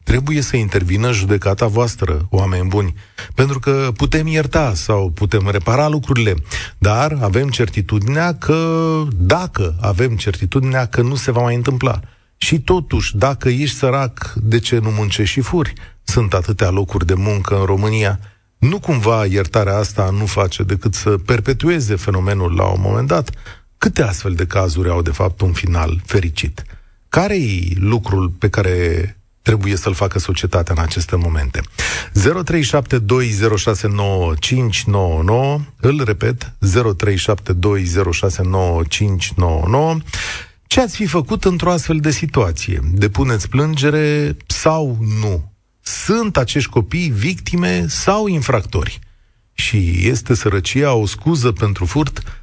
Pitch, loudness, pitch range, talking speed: 105 Hz, -16 LUFS, 95-130 Hz, 125 wpm